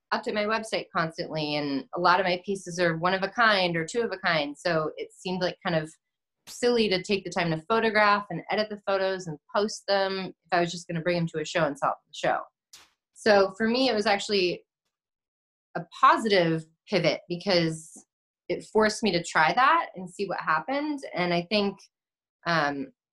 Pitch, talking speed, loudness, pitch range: 185 Hz, 205 wpm, -26 LUFS, 170-210 Hz